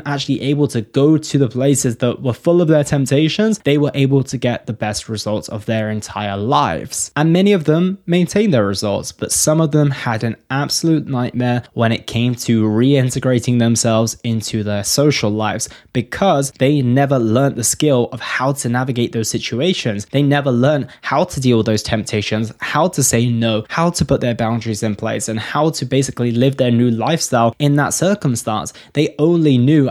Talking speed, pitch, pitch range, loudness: 195 wpm, 125 Hz, 115-145 Hz, -16 LUFS